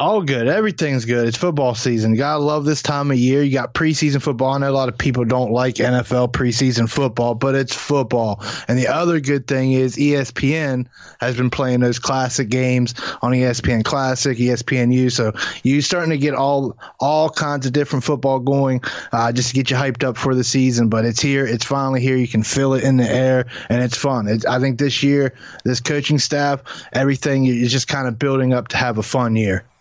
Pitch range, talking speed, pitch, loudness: 125-140 Hz, 215 wpm, 130 Hz, -18 LUFS